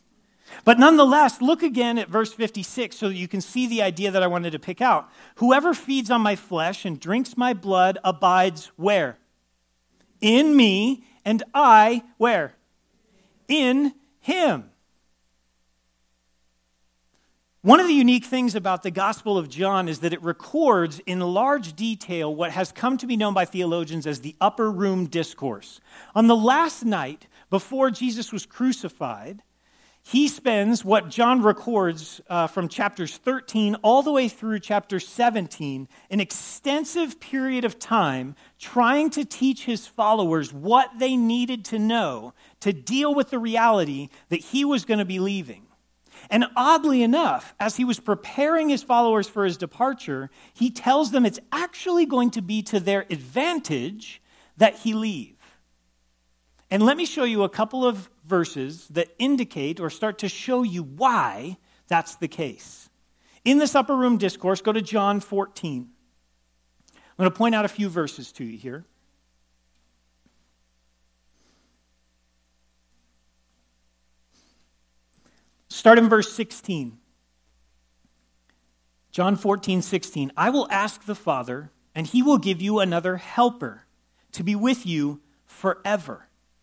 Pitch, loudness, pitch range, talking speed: 200 Hz, -22 LUFS, 145-240 Hz, 145 wpm